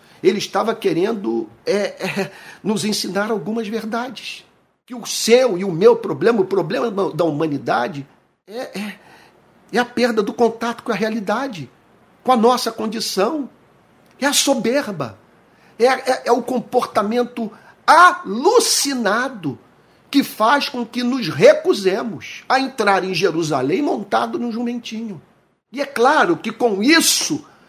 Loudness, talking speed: -18 LUFS, 135 wpm